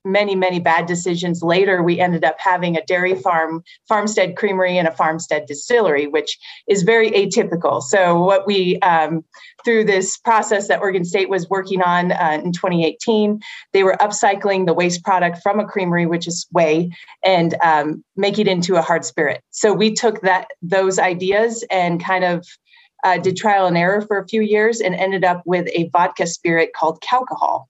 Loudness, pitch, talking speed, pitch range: -17 LUFS, 185 Hz, 185 wpm, 175-205 Hz